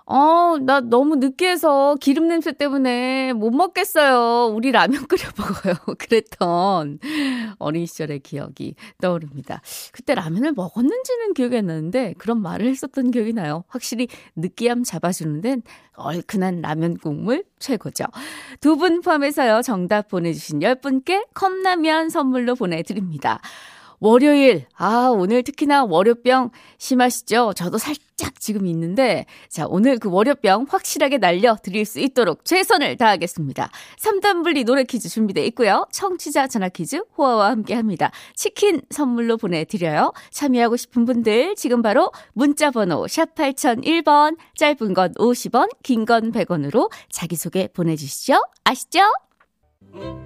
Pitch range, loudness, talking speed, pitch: 195-290 Hz, -19 LUFS, 305 characters per minute, 245 Hz